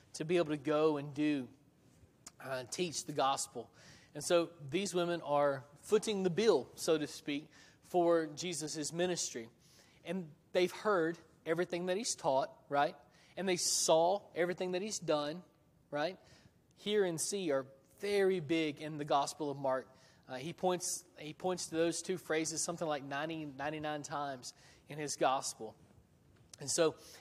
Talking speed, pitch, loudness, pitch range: 155 wpm, 155 Hz, -36 LUFS, 145-175 Hz